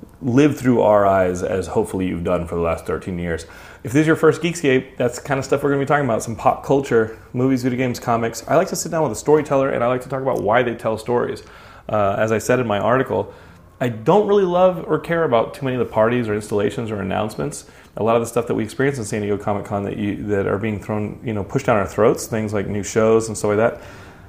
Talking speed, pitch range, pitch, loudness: 270 wpm, 105-135 Hz, 115 Hz, -19 LUFS